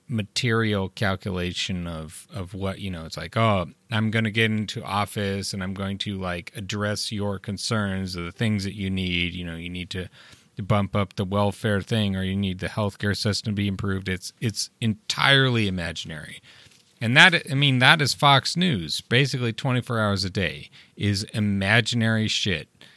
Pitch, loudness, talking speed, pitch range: 100 Hz, -24 LUFS, 185 wpm, 95-115 Hz